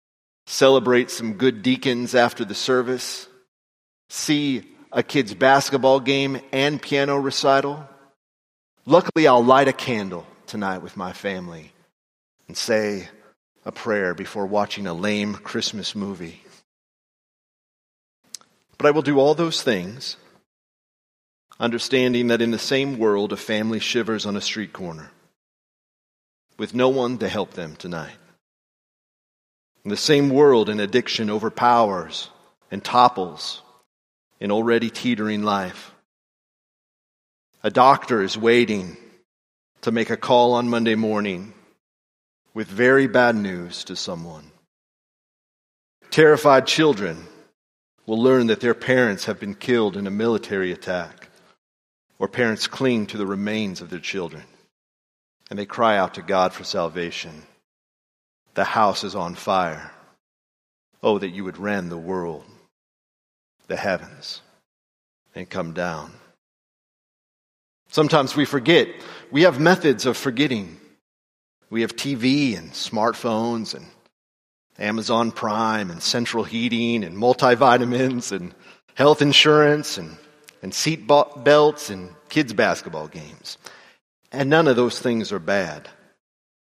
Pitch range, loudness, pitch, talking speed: 100-135 Hz, -20 LUFS, 115 Hz, 125 wpm